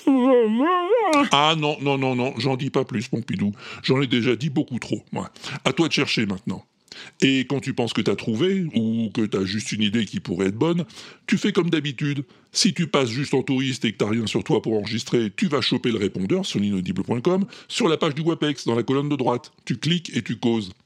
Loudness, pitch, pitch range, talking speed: -23 LUFS, 135 Hz, 115-165 Hz, 225 wpm